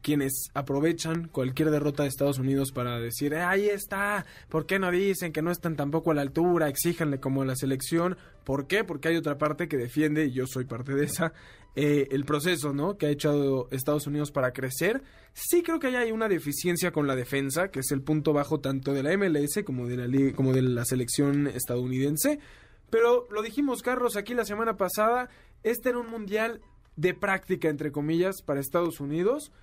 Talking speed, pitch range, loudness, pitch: 205 wpm, 140-185 Hz, -28 LUFS, 150 Hz